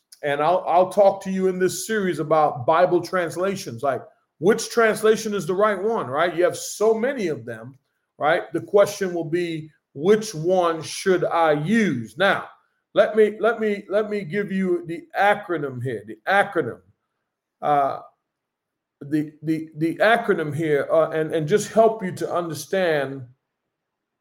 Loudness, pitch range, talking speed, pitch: -22 LUFS, 155-205 Hz, 160 wpm, 180 Hz